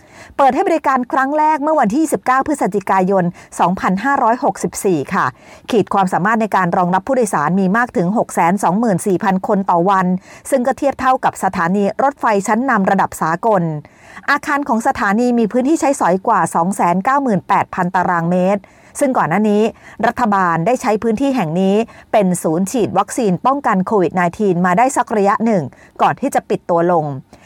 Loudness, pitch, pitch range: -15 LUFS, 205 Hz, 185-255 Hz